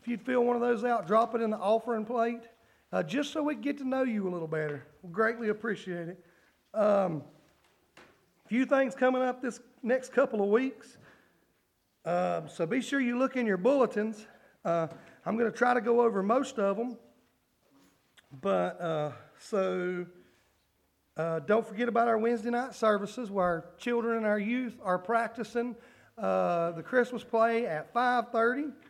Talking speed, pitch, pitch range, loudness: 180 wpm, 225 Hz, 180-240 Hz, -30 LUFS